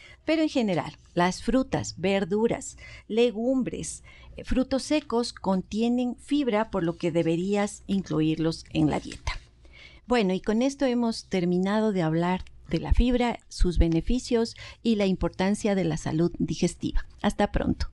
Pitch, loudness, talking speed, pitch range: 205 Hz, -27 LUFS, 135 wpm, 170-240 Hz